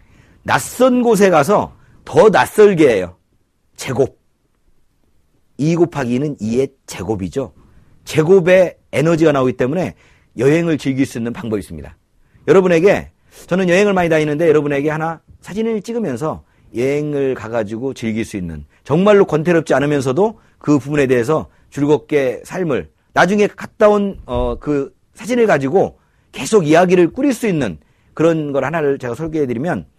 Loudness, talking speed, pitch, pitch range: -16 LUFS, 310 characters per minute, 150 Hz, 125-185 Hz